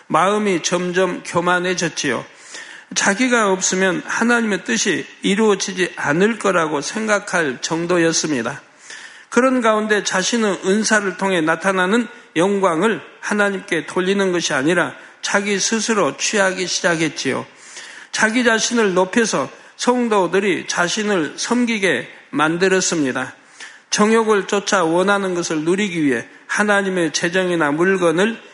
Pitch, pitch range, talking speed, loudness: 195 Hz, 175-215 Hz, 290 characters per minute, -18 LUFS